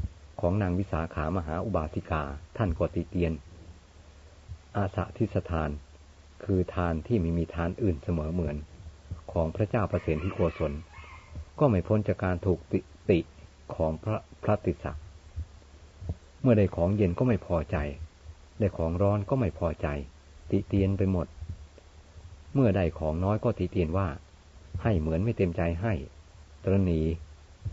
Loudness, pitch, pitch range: -29 LUFS, 85 Hz, 80-95 Hz